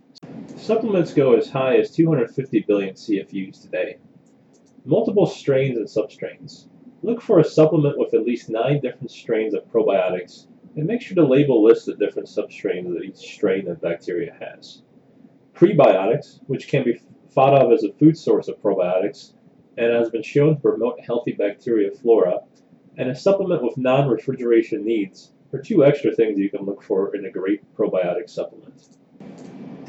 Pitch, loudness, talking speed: 160 Hz, -20 LUFS, 160 wpm